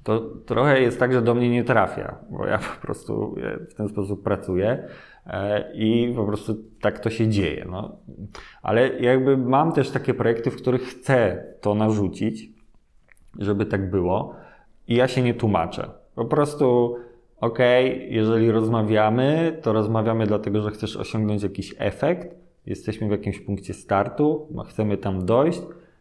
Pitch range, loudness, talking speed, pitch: 105-125 Hz, -23 LUFS, 155 wpm, 110 Hz